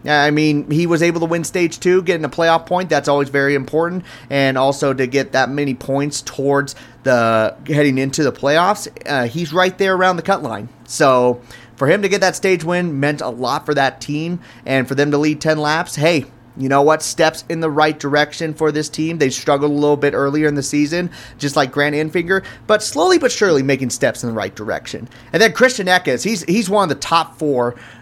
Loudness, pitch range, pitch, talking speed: -16 LUFS, 135-170 Hz, 150 Hz, 225 wpm